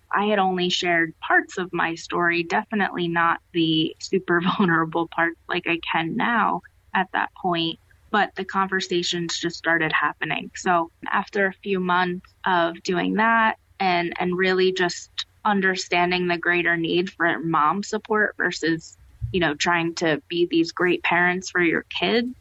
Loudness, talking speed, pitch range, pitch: -22 LUFS, 155 wpm, 170-190 Hz, 175 Hz